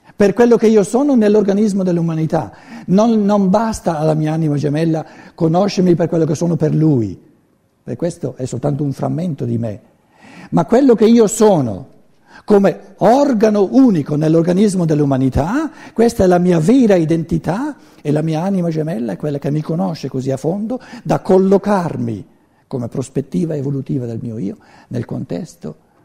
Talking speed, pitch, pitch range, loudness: 155 wpm, 170 Hz, 150-210 Hz, -15 LUFS